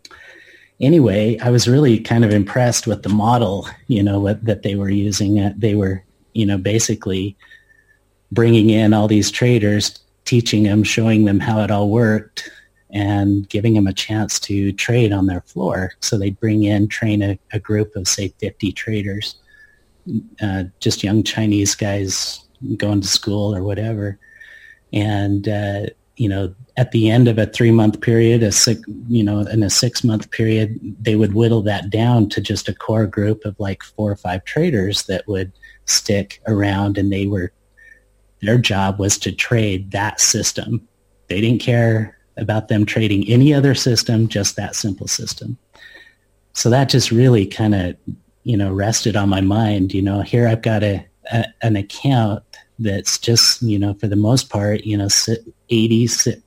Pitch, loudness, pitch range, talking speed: 105 Hz, -17 LUFS, 100-115 Hz, 170 wpm